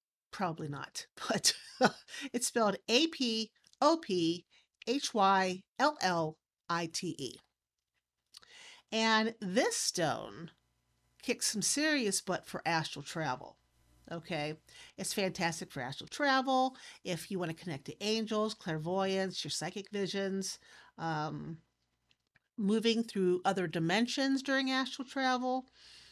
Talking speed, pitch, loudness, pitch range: 95 wpm, 195 Hz, -33 LUFS, 165-240 Hz